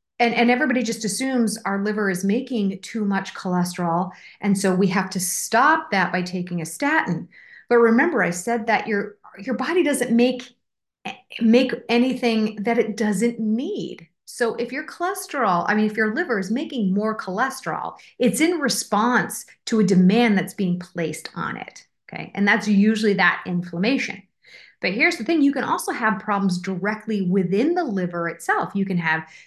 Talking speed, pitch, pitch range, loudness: 175 wpm, 215 Hz, 190-240 Hz, -21 LUFS